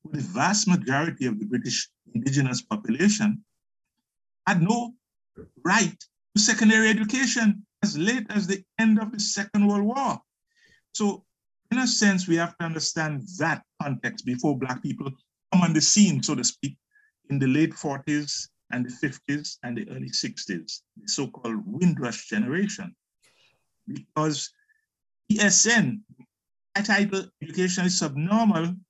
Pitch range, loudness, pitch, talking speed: 155-215 Hz, -24 LUFS, 195 Hz, 135 wpm